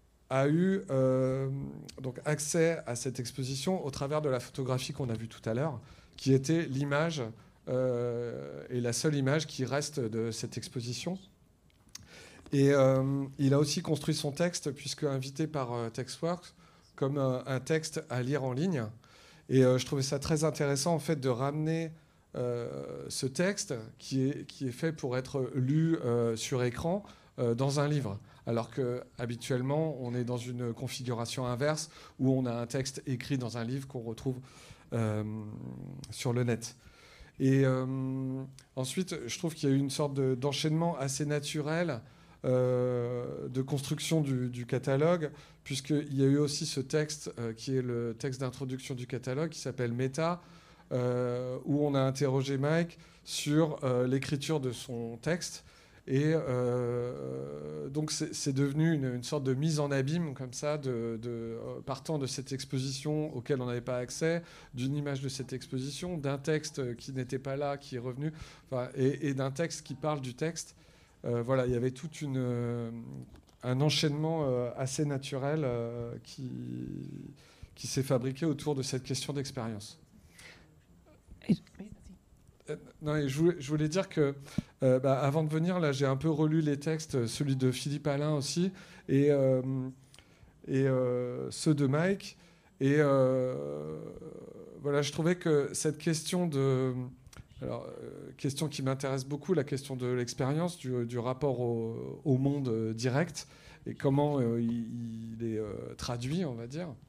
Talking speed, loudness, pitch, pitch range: 165 wpm, -32 LUFS, 135 Hz, 125-150 Hz